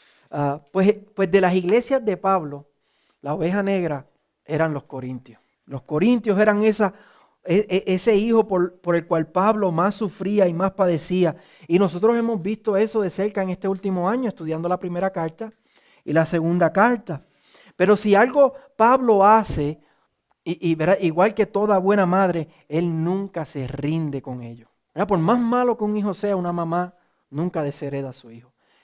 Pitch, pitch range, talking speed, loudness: 185 Hz, 160-205 Hz, 175 wpm, -21 LUFS